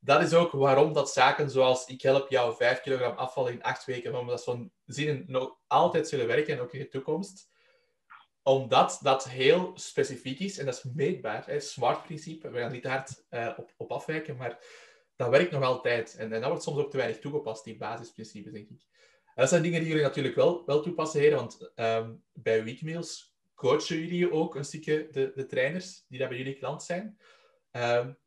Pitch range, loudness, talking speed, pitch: 130-170 Hz, -29 LUFS, 200 wpm, 145 Hz